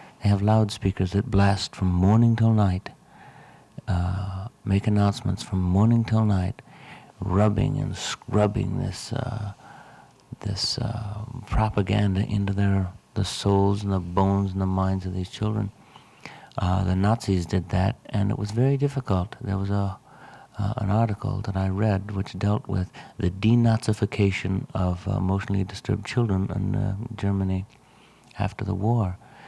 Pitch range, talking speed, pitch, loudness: 95-110 Hz, 145 wpm, 100 Hz, -25 LUFS